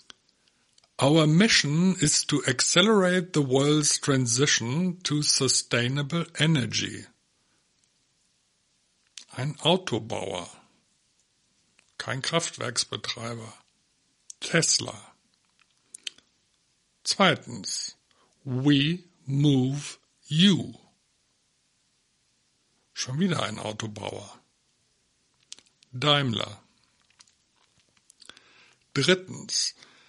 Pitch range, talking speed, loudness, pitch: 125-160 Hz, 50 wpm, -24 LUFS, 145 Hz